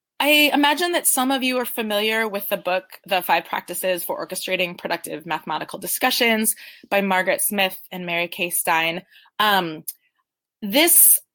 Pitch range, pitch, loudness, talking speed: 185-255 Hz, 205 Hz, -19 LUFS, 150 wpm